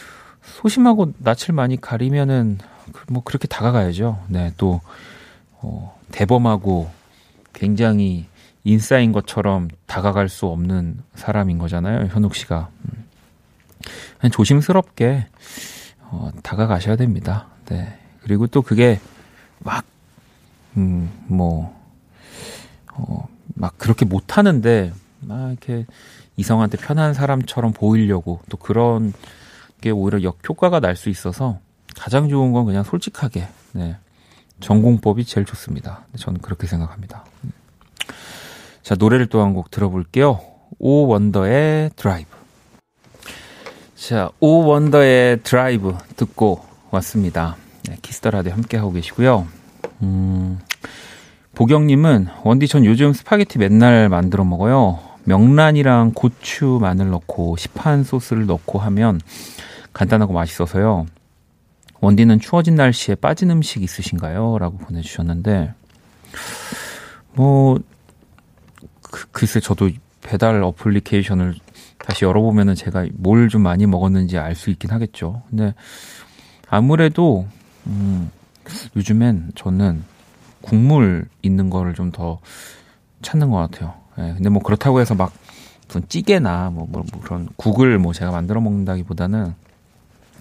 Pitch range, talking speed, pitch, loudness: 90-120 Hz, 255 characters per minute, 105 Hz, -17 LUFS